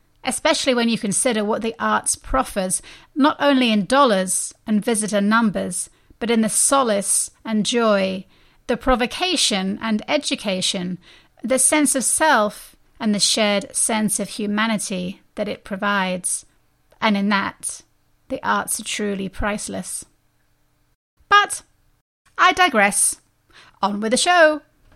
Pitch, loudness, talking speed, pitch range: 220 Hz, -19 LUFS, 125 wpm, 200-260 Hz